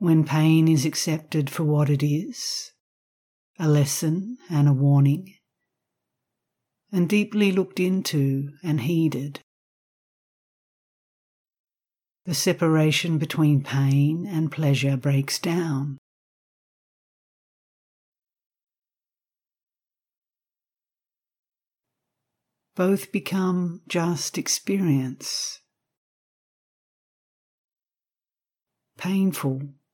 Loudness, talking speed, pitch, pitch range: -23 LUFS, 65 wpm, 155 Hz, 140-180 Hz